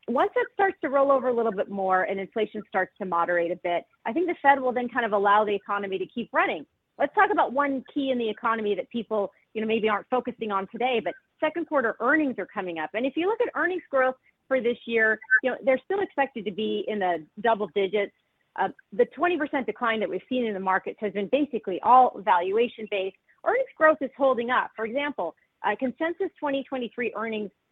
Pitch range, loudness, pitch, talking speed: 205-275 Hz, -26 LUFS, 230 Hz, 225 wpm